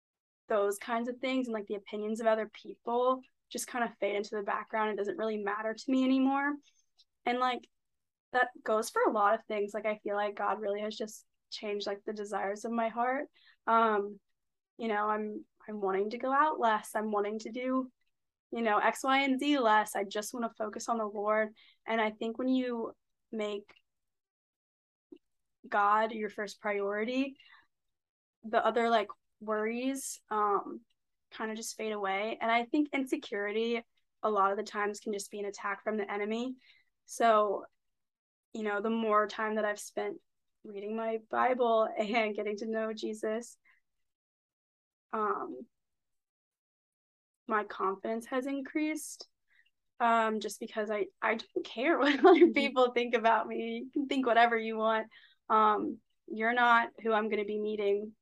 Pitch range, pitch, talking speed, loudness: 210-250 Hz, 220 Hz, 170 wpm, -32 LUFS